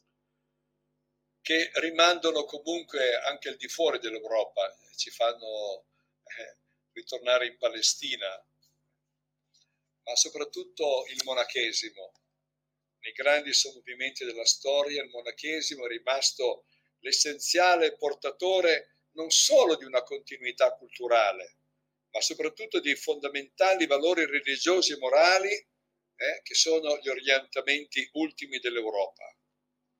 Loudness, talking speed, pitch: -27 LUFS, 100 wpm, 160 Hz